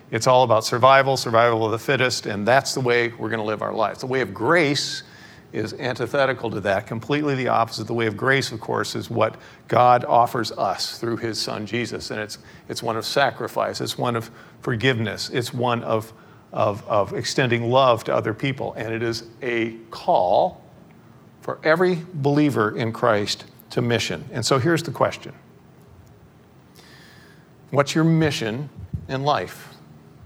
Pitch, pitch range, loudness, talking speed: 120 Hz, 115-135 Hz, -22 LUFS, 170 wpm